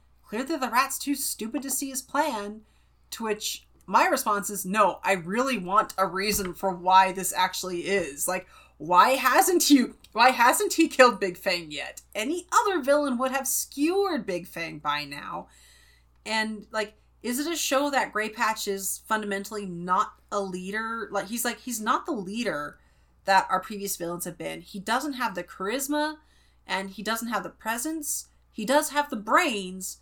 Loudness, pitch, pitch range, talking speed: -26 LUFS, 215 Hz, 190-270 Hz, 180 wpm